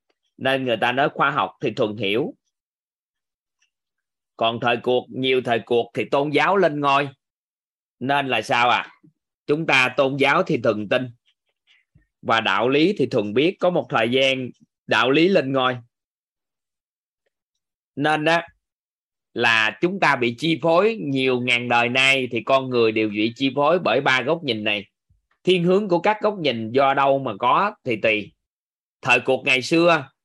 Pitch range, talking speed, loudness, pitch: 120-150 Hz, 170 wpm, -20 LUFS, 135 Hz